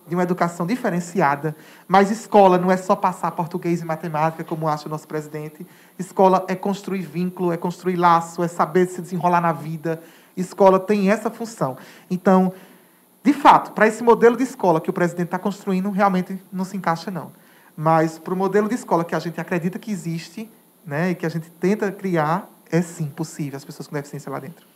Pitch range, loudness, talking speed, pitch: 165-195 Hz, -21 LUFS, 195 wpm, 180 Hz